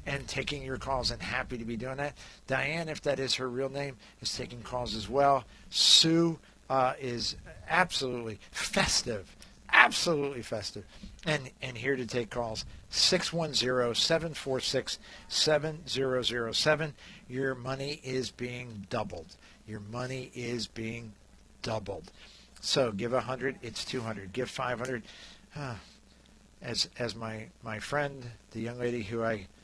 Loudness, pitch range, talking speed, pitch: -30 LUFS, 115-135 Hz, 130 wpm, 125 Hz